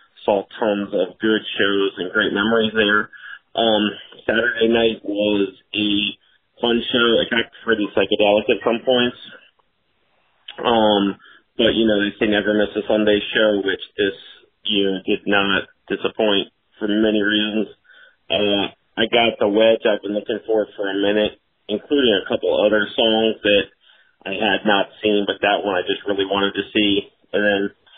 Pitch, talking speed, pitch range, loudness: 105 Hz, 165 wpm, 100-110 Hz, -19 LUFS